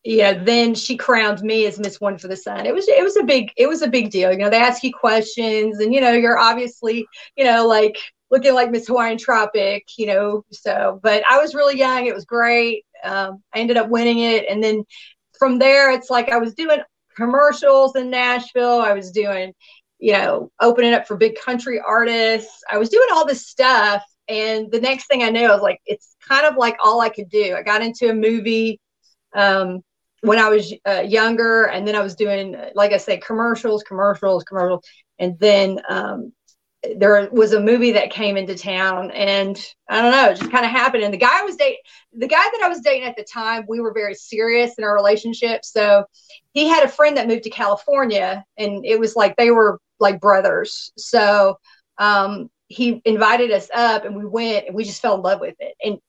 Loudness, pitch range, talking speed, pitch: -17 LUFS, 205-250 Hz, 215 wpm, 225 Hz